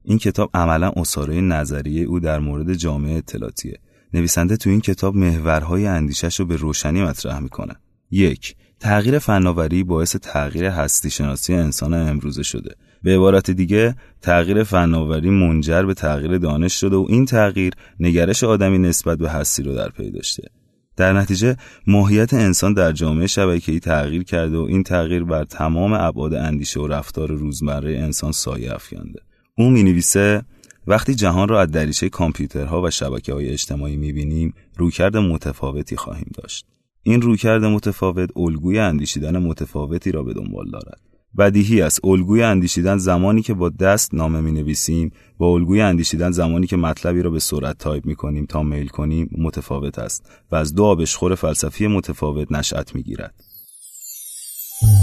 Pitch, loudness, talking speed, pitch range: 85 Hz, -18 LUFS, 155 wpm, 75-95 Hz